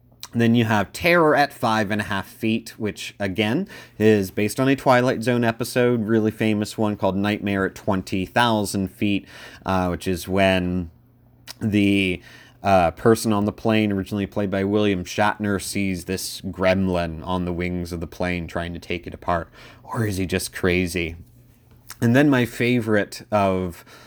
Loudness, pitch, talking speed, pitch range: -22 LUFS, 105 Hz, 165 wpm, 95-115 Hz